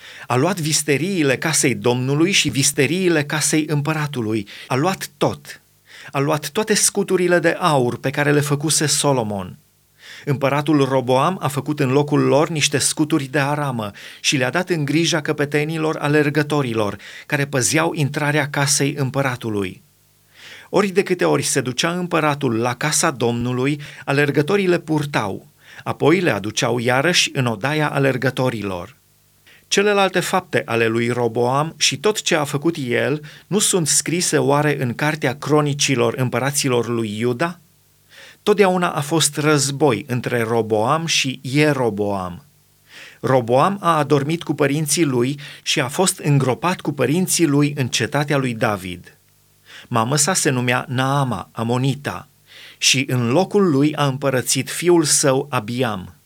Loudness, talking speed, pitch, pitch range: -18 LUFS, 135 wpm, 145 Hz, 130-155 Hz